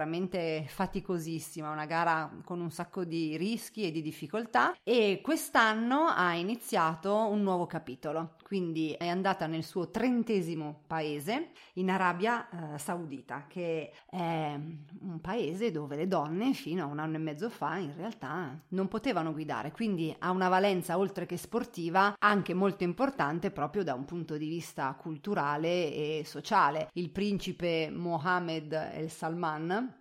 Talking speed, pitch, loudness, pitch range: 145 wpm, 175 Hz, -32 LUFS, 155-195 Hz